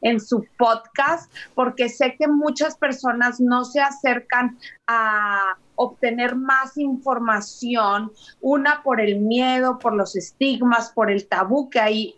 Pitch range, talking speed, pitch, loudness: 220-265 Hz, 135 wpm, 245 Hz, -21 LUFS